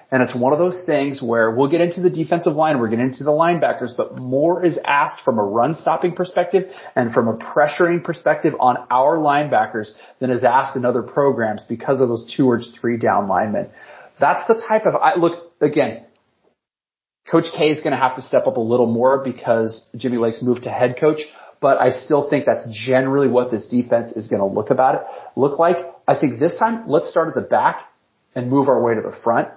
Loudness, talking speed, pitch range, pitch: -18 LUFS, 220 wpm, 120-165 Hz, 135 Hz